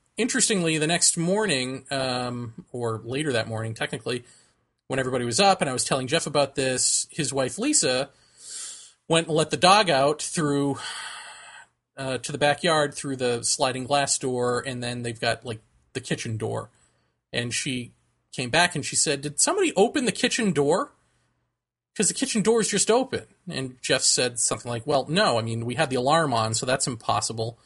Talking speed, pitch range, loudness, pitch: 185 wpm, 125-165 Hz, -24 LUFS, 140 Hz